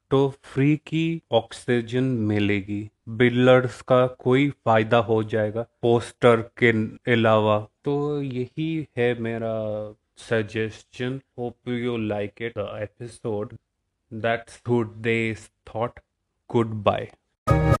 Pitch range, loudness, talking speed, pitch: 110-125 Hz, -24 LUFS, 90 wpm, 115 Hz